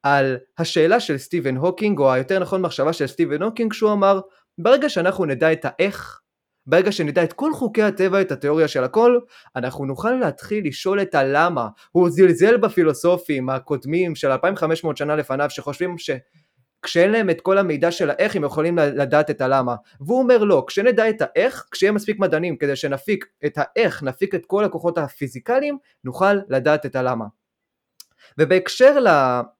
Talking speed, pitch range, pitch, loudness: 160 wpm, 145-195 Hz, 170 Hz, -19 LUFS